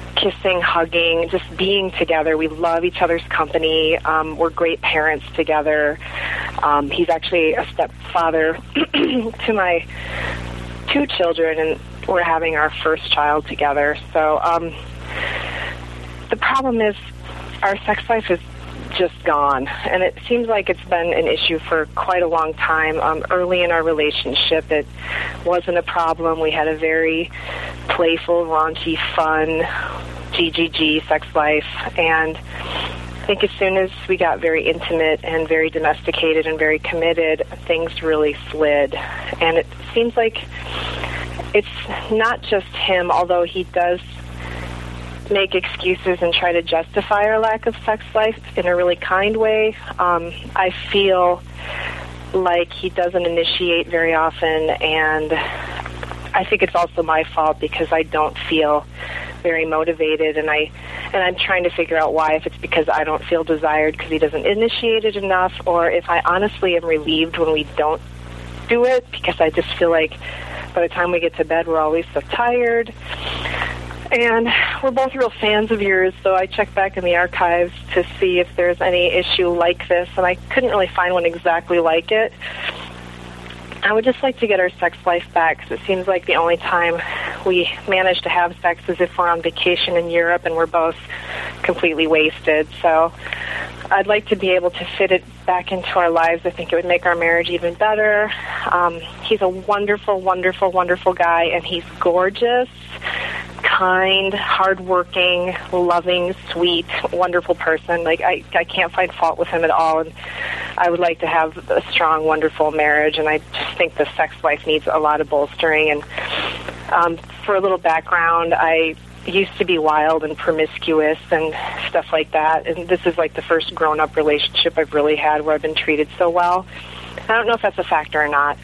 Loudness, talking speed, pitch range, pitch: -18 LUFS, 175 wpm, 155-180 Hz, 165 Hz